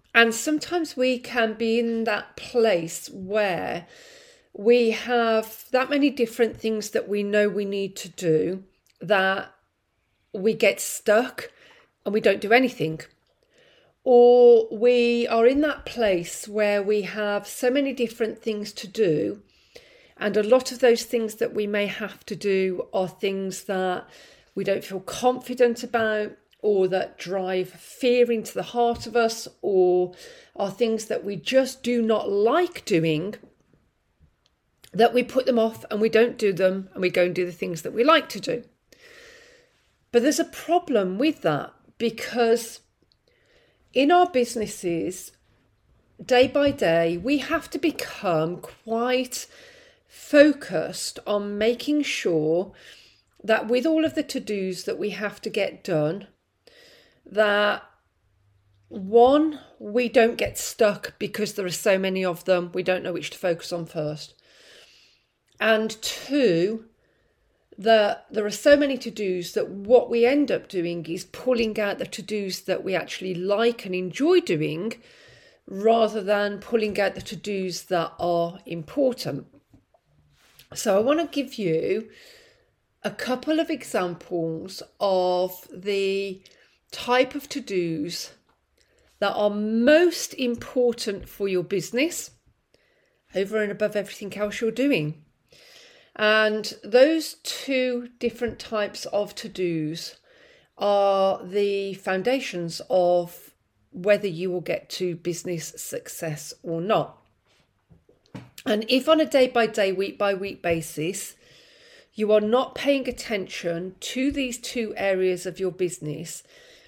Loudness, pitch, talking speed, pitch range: -24 LUFS, 215 Hz, 140 wpm, 185-250 Hz